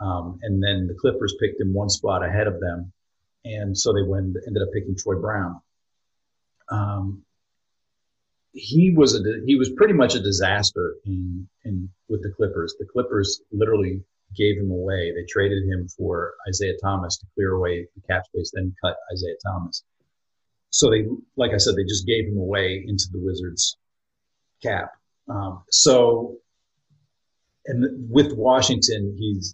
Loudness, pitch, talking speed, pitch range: -22 LUFS, 100 Hz, 160 wpm, 95-110 Hz